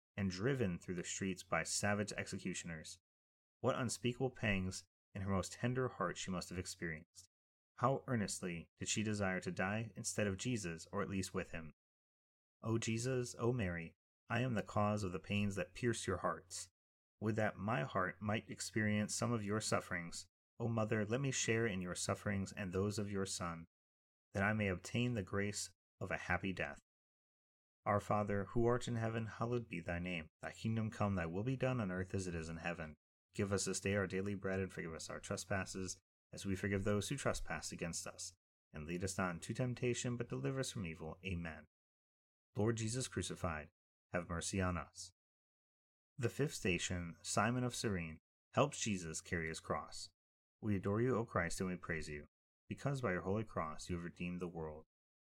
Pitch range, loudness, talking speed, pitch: 85-110 Hz, -41 LUFS, 190 wpm, 95 Hz